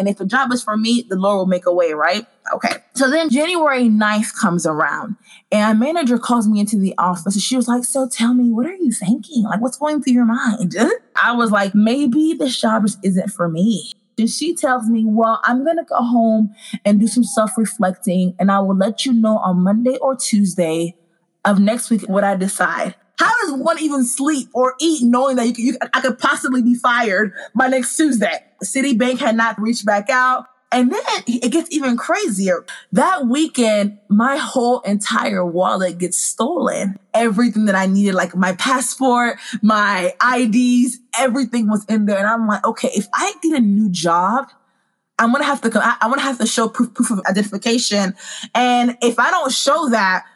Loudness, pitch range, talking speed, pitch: -17 LUFS, 205-255 Hz, 200 wpm, 230 Hz